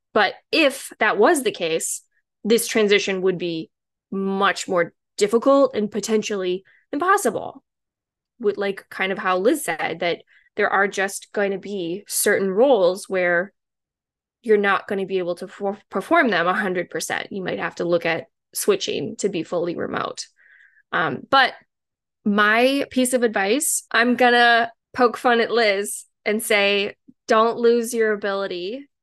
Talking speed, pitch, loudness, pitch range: 155 wpm, 210 Hz, -21 LUFS, 195-235 Hz